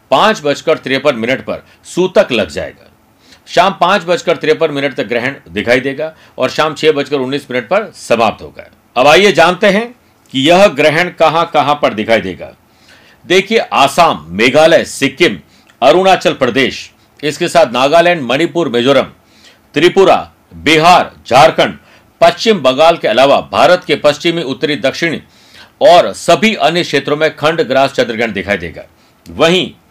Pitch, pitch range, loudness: 155 Hz, 140-175 Hz, -11 LUFS